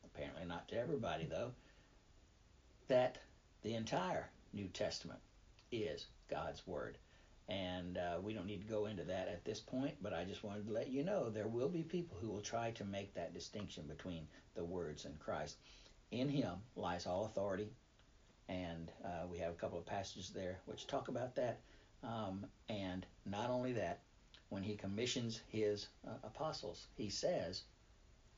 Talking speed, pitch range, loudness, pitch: 170 wpm, 90-110 Hz, -45 LUFS, 105 Hz